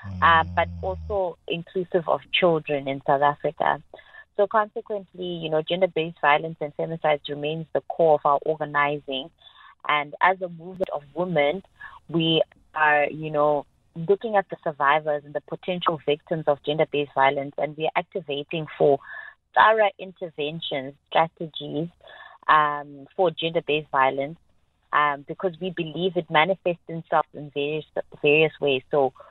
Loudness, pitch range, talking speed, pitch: -24 LUFS, 145-175 Hz, 140 wpm, 155 Hz